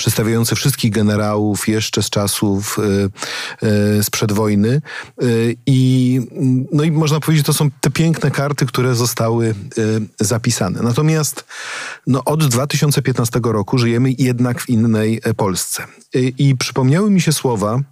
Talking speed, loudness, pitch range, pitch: 135 wpm, -16 LUFS, 110-140 Hz, 125 Hz